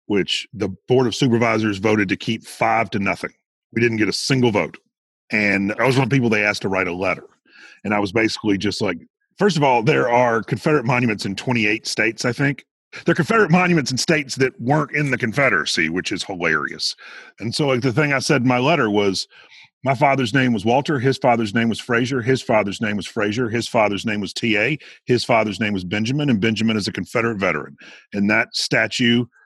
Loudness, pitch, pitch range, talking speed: -19 LUFS, 120 Hz, 105-135 Hz, 220 wpm